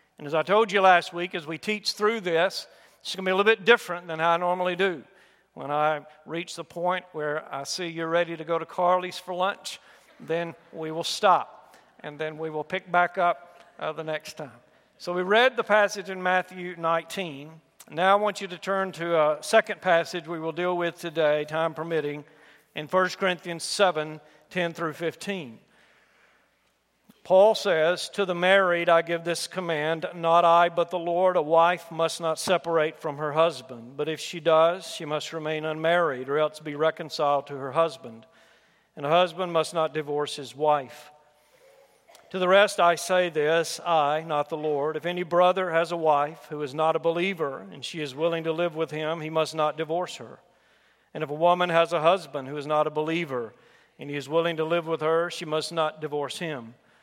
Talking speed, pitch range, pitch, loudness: 200 wpm, 155-180 Hz, 165 Hz, -25 LUFS